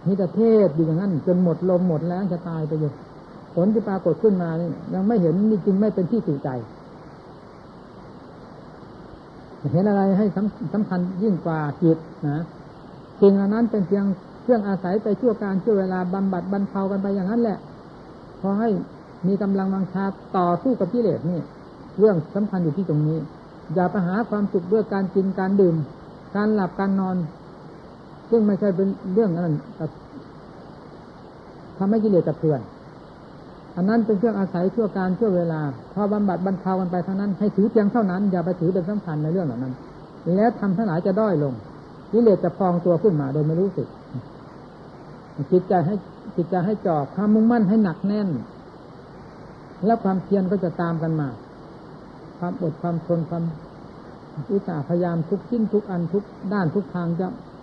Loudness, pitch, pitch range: -22 LUFS, 190 Hz, 170-205 Hz